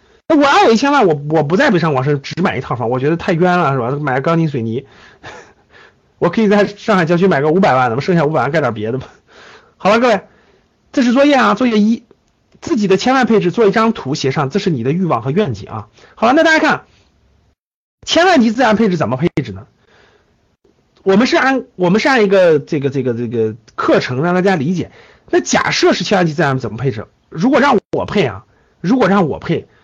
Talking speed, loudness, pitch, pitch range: 320 characters per minute, -14 LUFS, 180 Hz, 135-220 Hz